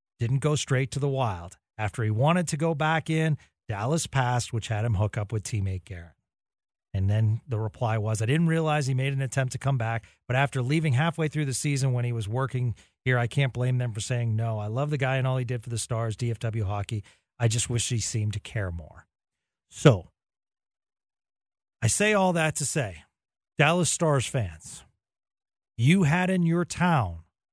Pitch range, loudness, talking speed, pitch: 110-145 Hz, -27 LUFS, 205 wpm, 125 Hz